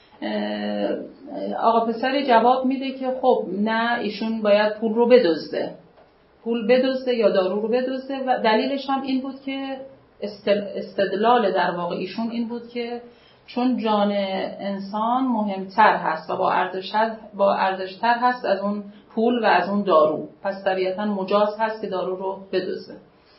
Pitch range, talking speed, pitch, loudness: 195-240 Hz, 140 wpm, 215 Hz, -22 LUFS